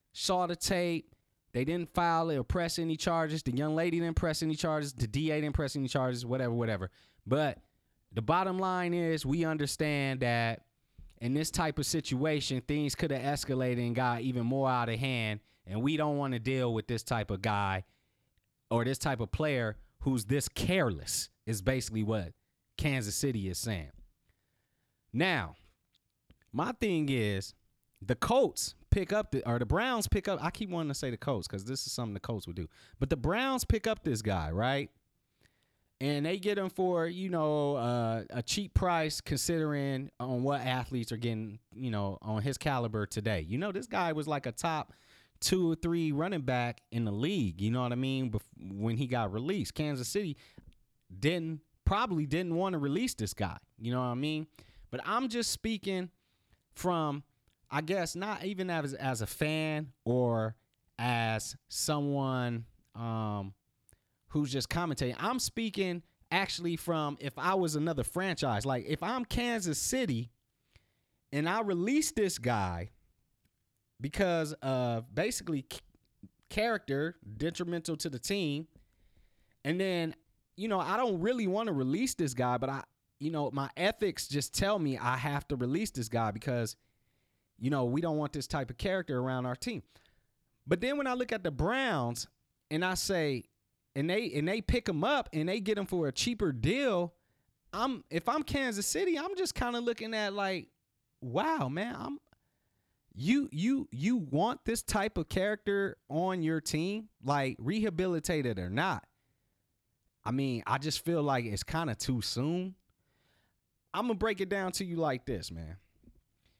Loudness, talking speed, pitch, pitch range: -33 LUFS, 175 wpm, 140 Hz, 115-170 Hz